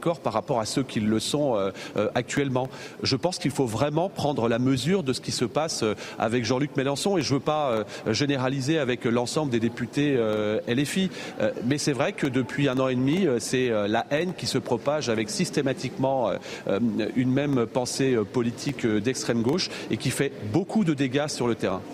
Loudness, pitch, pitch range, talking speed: -26 LUFS, 135 Hz, 120-145 Hz, 185 wpm